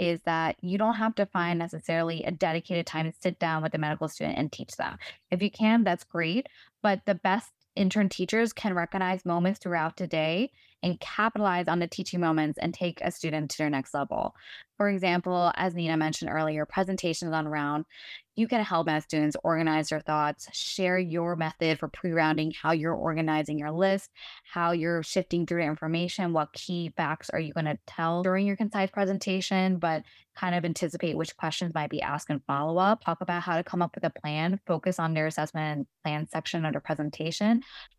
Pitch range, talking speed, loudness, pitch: 155-185 Hz, 195 wpm, -29 LUFS, 170 Hz